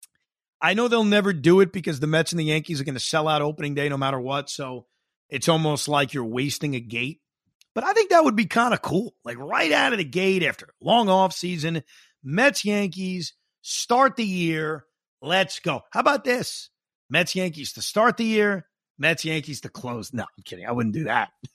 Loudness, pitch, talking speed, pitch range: -23 LUFS, 165 Hz, 205 wpm, 145-200 Hz